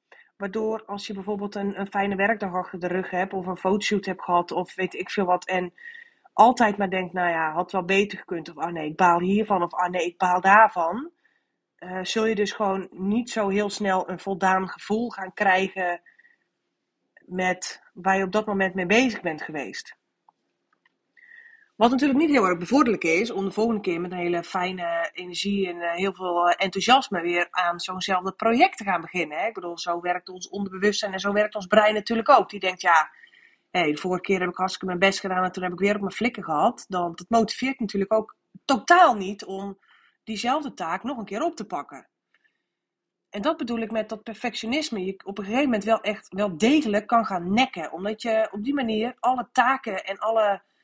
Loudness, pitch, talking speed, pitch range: -24 LUFS, 200 Hz, 205 wpm, 185-225 Hz